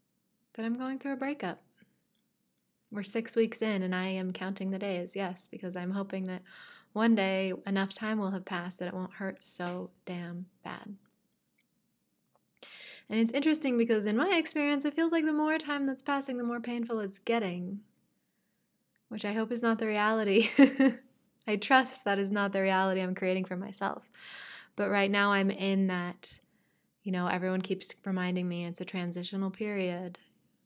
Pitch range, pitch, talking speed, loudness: 185-230 Hz, 200 Hz, 175 wpm, -31 LUFS